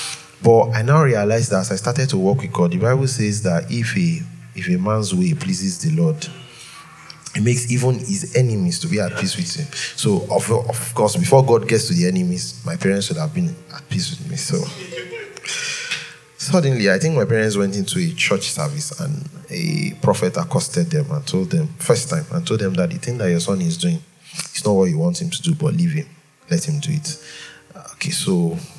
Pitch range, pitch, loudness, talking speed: 120-170 Hz, 155 Hz, -19 LUFS, 215 wpm